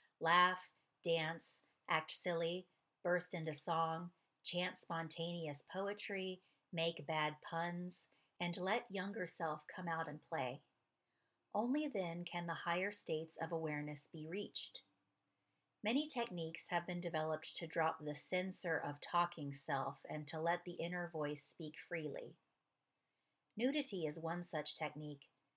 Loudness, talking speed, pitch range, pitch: -42 LUFS, 130 wpm, 155-180 Hz, 165 Hz